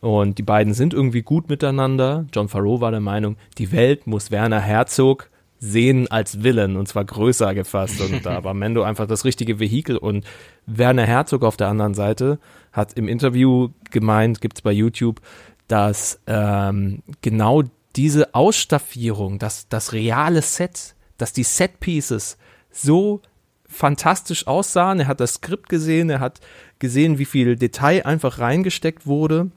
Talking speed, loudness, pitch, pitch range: 155 wpm, -19 LUFS, 120 Hz, 105-145 Hz